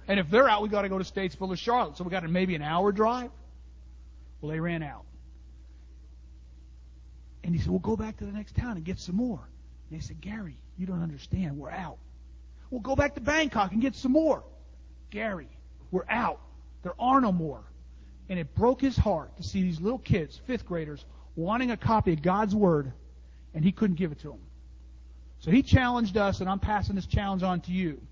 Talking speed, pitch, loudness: 215 wpm, 170 Hz, -28 LUFS